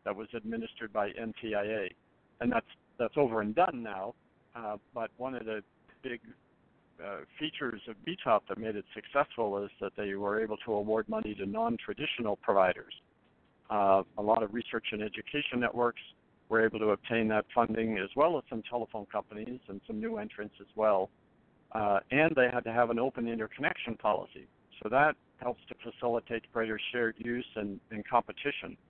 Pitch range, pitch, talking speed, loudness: 105-120 Hz, 115 Hz, 175 wpm, -33 LUFS